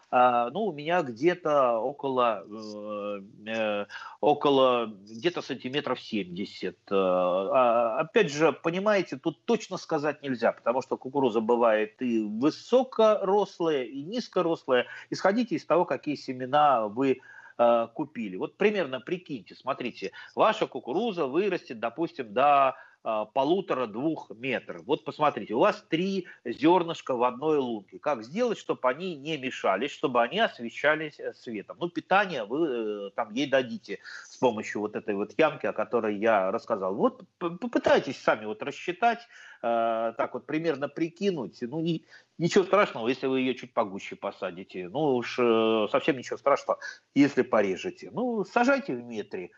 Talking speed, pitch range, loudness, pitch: 135 wpm, 120-185 Hz, -28 LUFS, 145 Hz